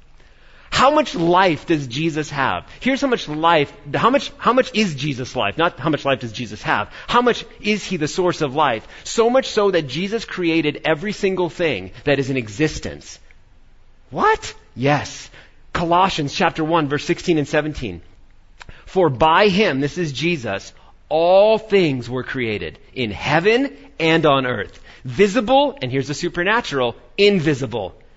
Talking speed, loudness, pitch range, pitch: 160 wpm, -19 LUFS, 135-200 Hz, 160 Hz